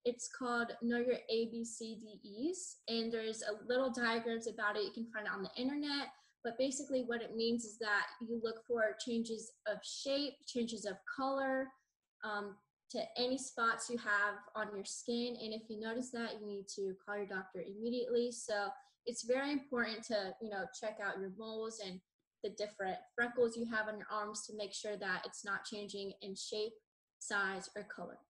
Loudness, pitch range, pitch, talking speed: -40 LUFS, 210-245 Hz, 225 Hz, 185 wpm